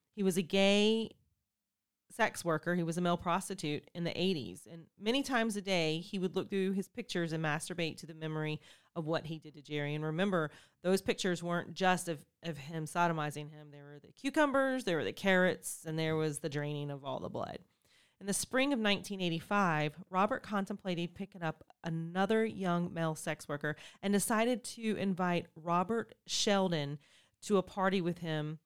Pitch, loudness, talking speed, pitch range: 175 Hz, -34 LUFS, 185 wpm, 160-195 Hz